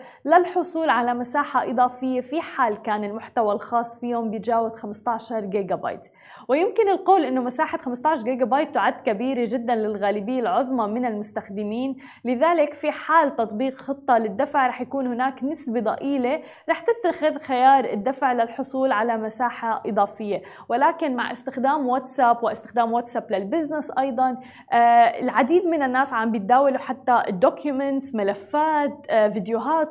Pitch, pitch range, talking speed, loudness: 255 Hz, 230-280 Hz, 130 wpm, -22 LUFS